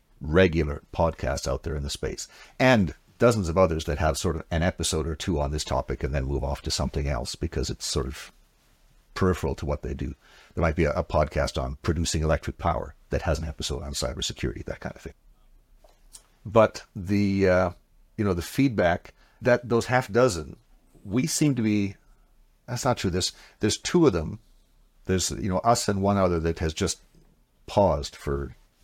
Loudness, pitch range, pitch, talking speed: -26 LUFS, 75-95 Hz, 85 Hz, 200 wpm